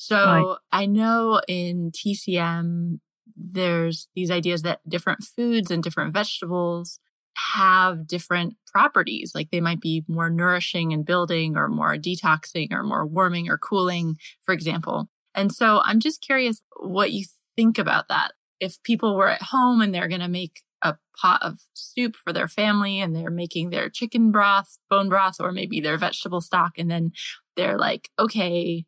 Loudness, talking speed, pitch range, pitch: -23 LUFS, 165 wpm, 170-205 Hz, 180 Hz